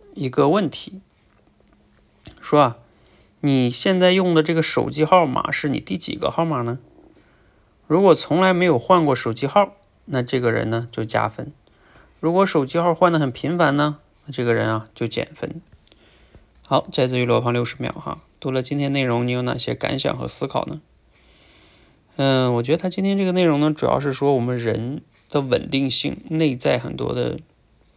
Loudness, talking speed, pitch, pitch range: -20 LUFS, 250 characters per minute, 135 Hz, 120-160 Hz